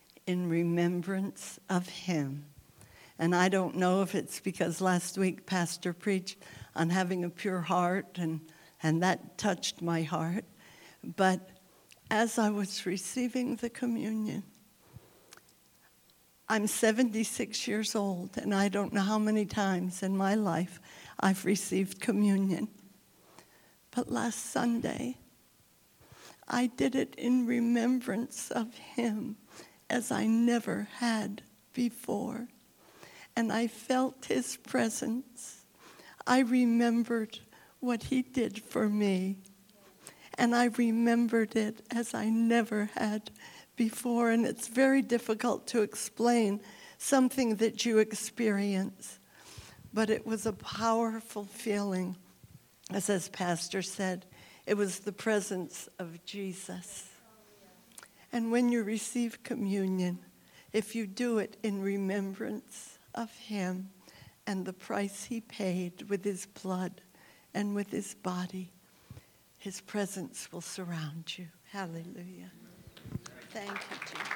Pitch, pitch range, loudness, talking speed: 205 Hz, 185-230 Hz, -32 LUFS, 115 wpm